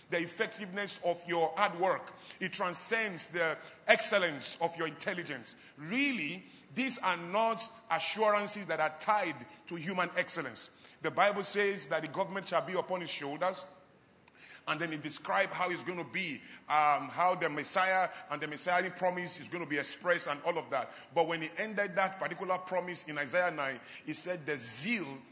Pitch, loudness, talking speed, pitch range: 180 Hz, -33 LUFS, 180 wpm, 160-195 Hz